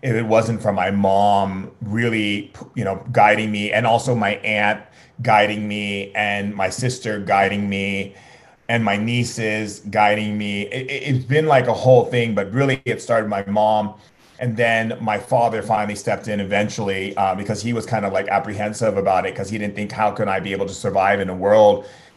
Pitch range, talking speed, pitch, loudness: 100-115 Hz, 200 wpm, 105 Hz, -19 LUFS